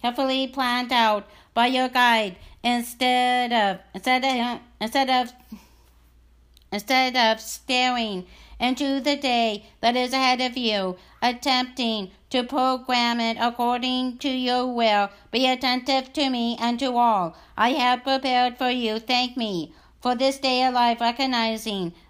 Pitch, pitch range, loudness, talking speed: 245 Hz, 225-255 Hz, -23 LUFS, 140 wpm